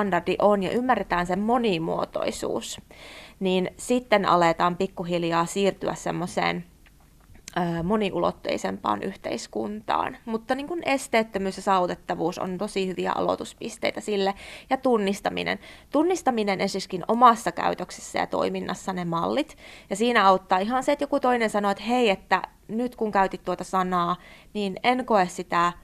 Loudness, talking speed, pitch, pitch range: -25 LUFS, 130 wpm, 195 Hz, 180-225 Hz